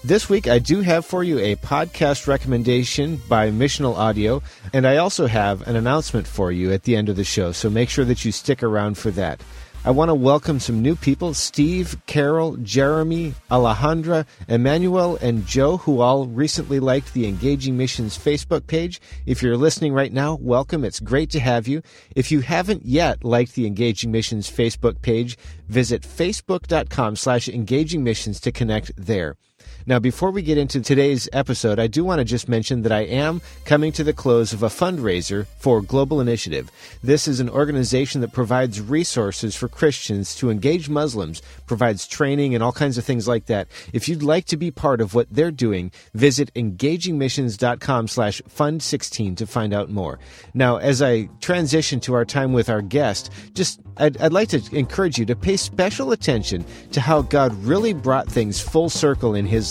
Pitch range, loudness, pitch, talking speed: 110-150 Hz, -20 LUFS, 125 Hz, 185 wpm